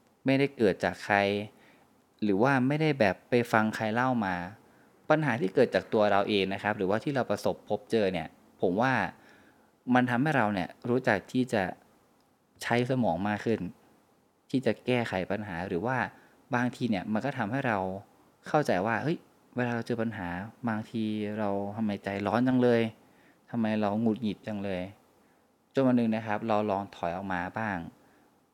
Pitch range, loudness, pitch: 100-120 Hz, -29 LUFS, 110 Hz